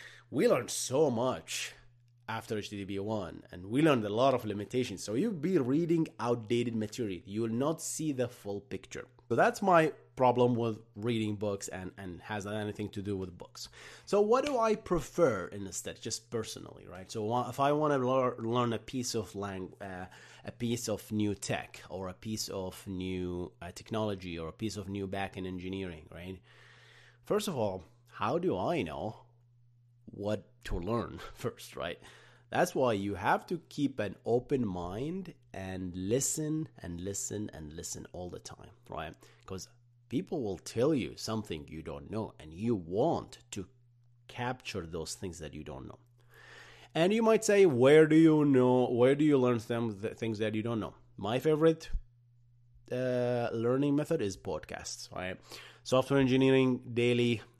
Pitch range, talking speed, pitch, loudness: 100-125 Hz, 170 wpm, 115 Hz, -32 LUFS